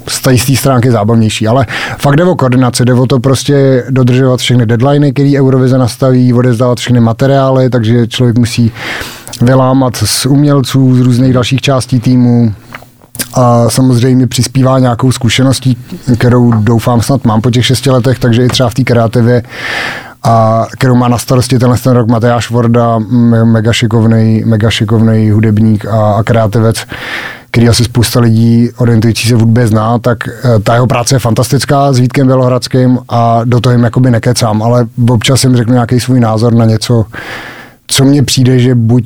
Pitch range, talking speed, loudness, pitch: 115-130 Hz, 160 wpm, -8 LUFS, 125 Hz